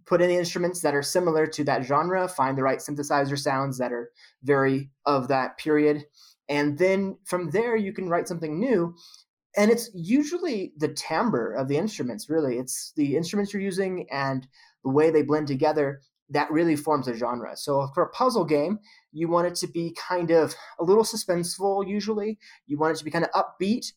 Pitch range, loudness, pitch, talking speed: 145-190 Hz, -25 LUFS, 160 Hz, 200 wpm